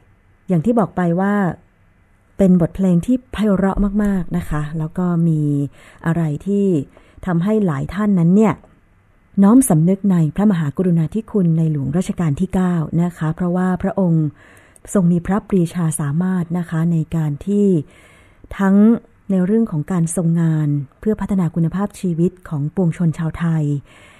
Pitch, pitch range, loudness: 170 Hz, 150-195 Hz, -18 LUFS